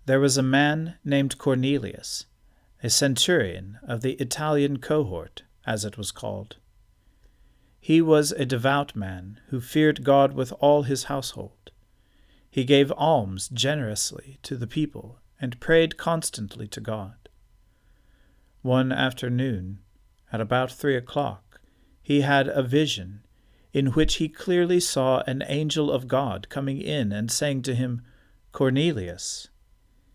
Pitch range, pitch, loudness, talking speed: 105-145 Hz, 130 Hz, -24 LUFS, 130 wpm